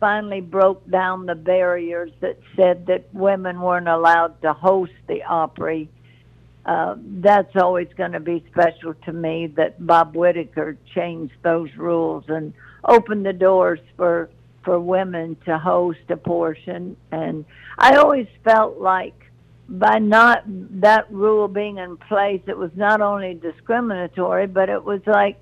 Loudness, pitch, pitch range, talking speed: -19 LUFS, 180 Hz, 165-195 Hz, 145 wpm